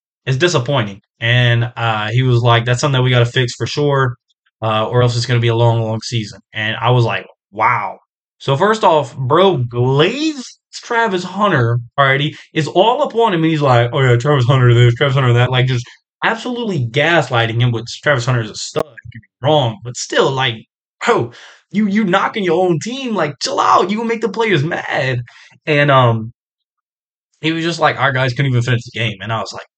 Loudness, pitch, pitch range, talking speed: -15 LUFS, 130 Hz, 120-155 Hz, 210 wpm